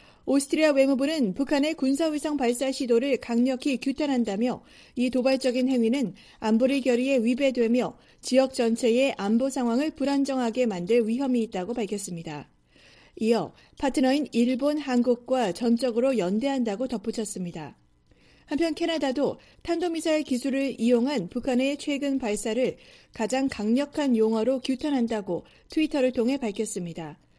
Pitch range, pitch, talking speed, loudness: 230-275 Hz, 255 Hz, 330 characters per minute, -26 LUFS